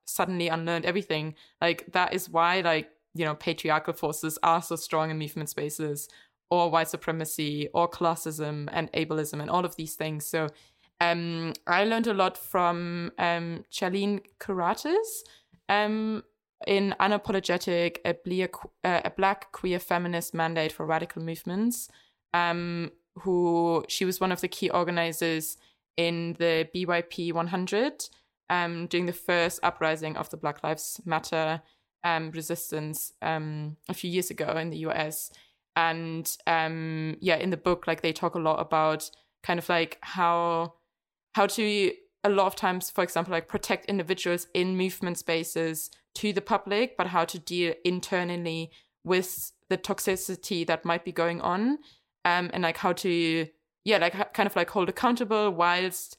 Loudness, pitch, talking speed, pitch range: -28 LUFS, 170 Hz, 155 wpm, 160-185 Hz